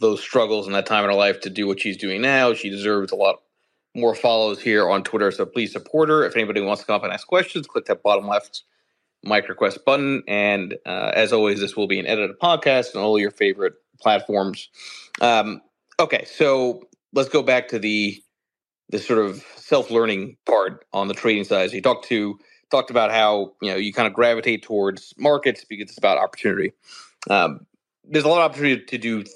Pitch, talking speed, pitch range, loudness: 110 Hz, 215 wpm, 105-135 Hz, -20 LUFS